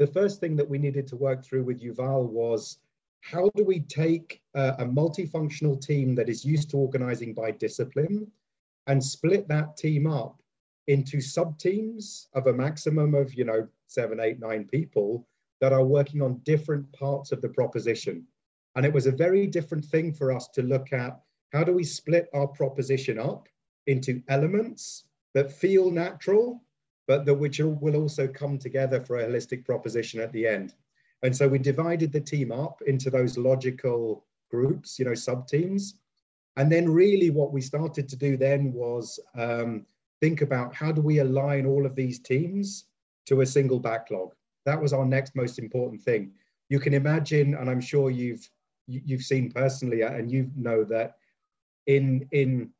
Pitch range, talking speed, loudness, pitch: 130-150 Hz, 175 wpm, -27 LUFS, 140 Hz